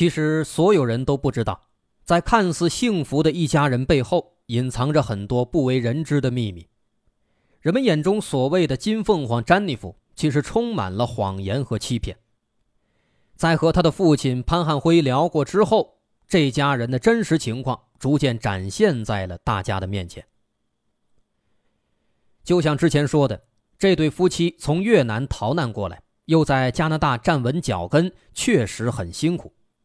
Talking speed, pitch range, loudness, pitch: 235 characters per minute, 115-170 Hz, -21 LUFS, 140 Hz